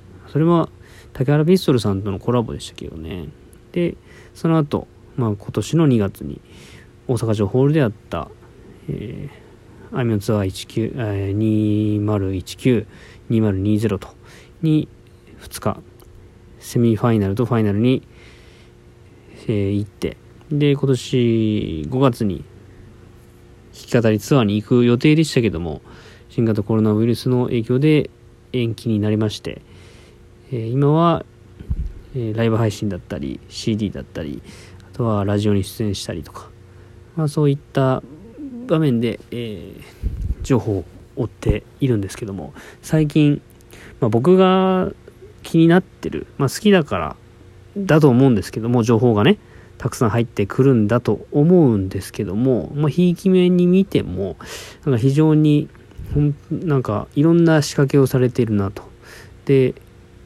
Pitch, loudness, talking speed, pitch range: 115 Hz, -19 LUFS, 265 characters per minute, 100-135 Hz